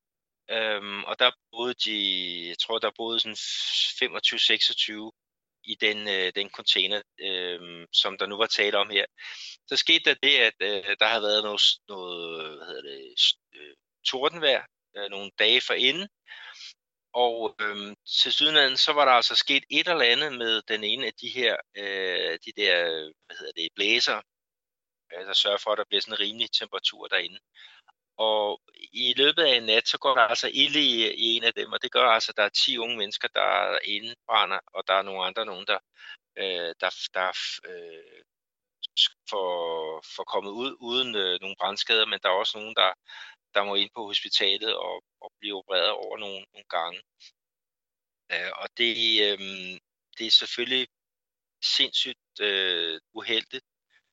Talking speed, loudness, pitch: 170 wpm, -24 LUFS, 115 Hz